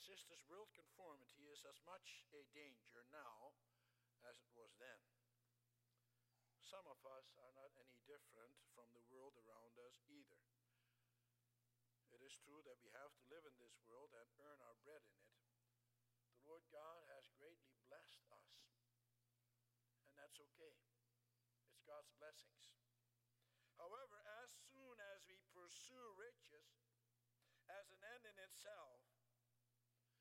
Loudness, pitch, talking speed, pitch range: -65 LUFS, 120 Hz, 135 wpm, 120-150 Hz